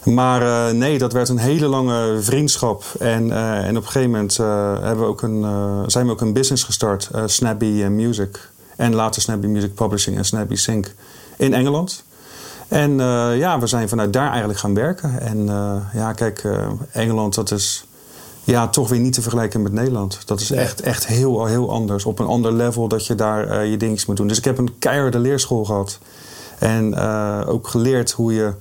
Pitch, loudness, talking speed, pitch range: 115 Hz, -19 LUFS, 205 wpm, 105-125 Hz